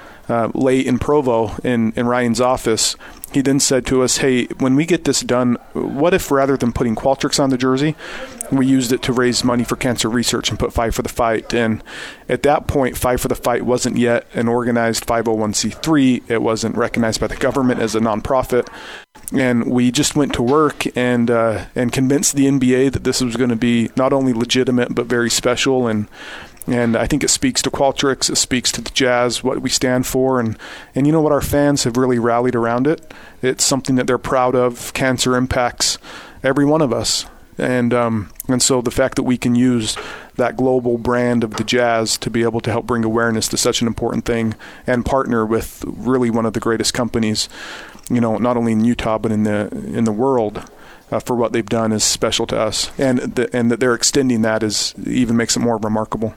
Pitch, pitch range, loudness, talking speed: 125 Hz, 115-130 Hz, -17 LUFS, 215 wpm